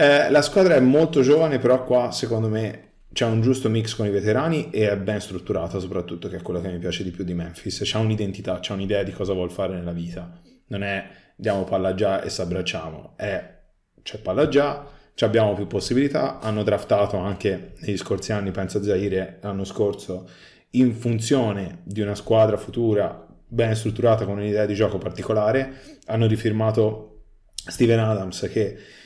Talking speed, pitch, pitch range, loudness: 180 wpm, 105 Hz, 95-115 Hz, -23 LUFS